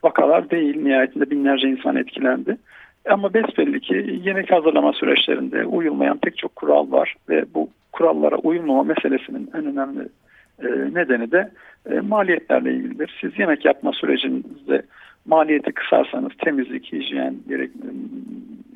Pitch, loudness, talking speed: 195 Hz, -20 LUFS, 115 wpm